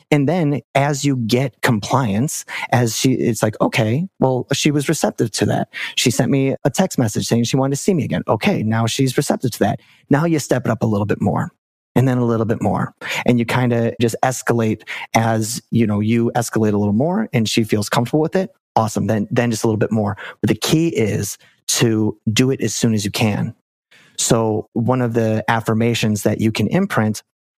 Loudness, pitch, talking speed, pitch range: -18 LUFS, 115 Hz, 215 wpm, 110-135 Hz